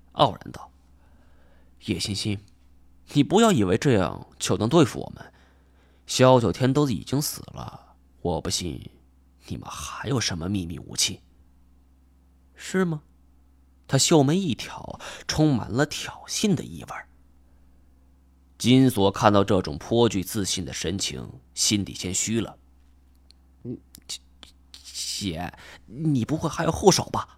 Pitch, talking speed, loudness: 70 Hz, 180 characters per minute, -24 LUFS